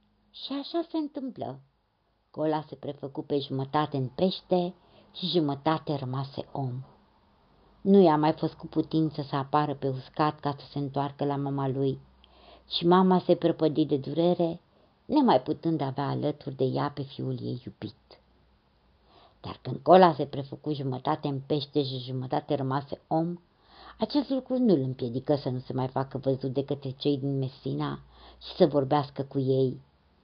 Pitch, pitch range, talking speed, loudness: 145 Hz, 135-160 Hz, 160 wpm, -28 LUFS